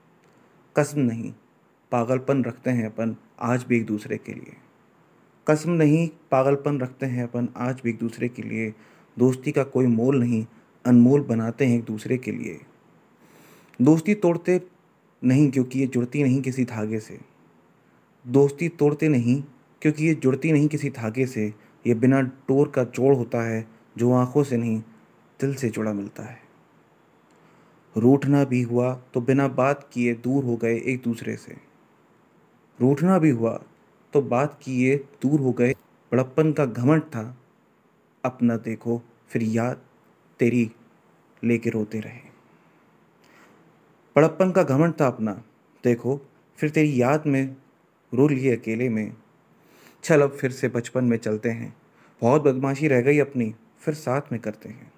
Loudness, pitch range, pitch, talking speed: -23 LUFS, 115-140 Hz, 125 Hz, 150 wpm